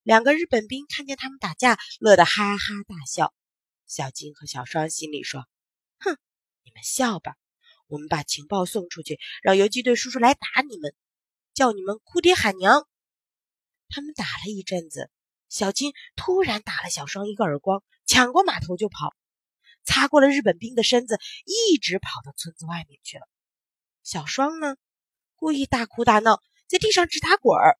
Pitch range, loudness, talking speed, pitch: 165-280 Hz, -22 LUFS, 250 characters per minute, 215 Hz